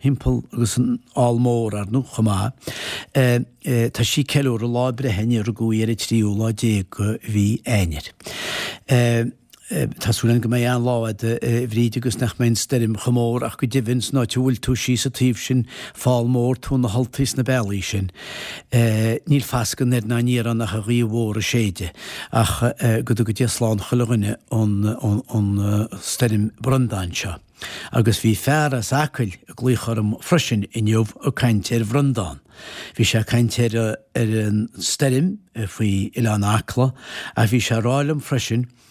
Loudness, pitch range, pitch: -21 LUFS, 110-125 Hz, 115 Hz